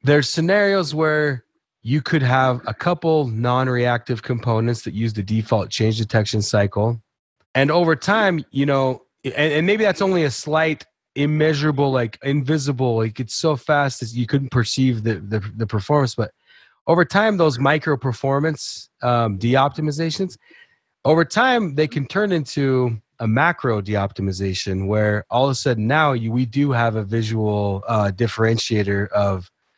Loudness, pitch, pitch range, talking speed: -20 LUFS, 130 Hz, 110-155 Hz, 155 wpm